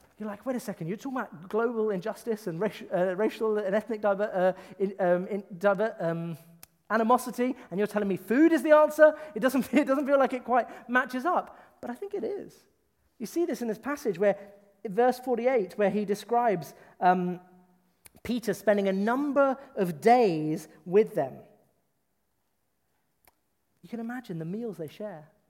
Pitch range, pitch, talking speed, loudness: 190-250 Hz, 215 Hz, 180 wpm, -27 LUFS